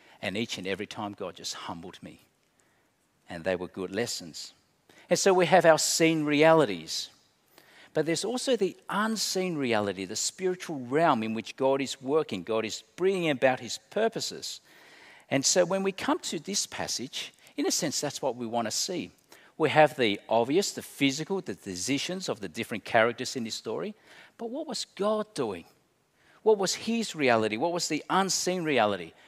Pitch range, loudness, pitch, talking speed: 115-190 Hz, -28 LUFS, 155 Hz, 180 wpm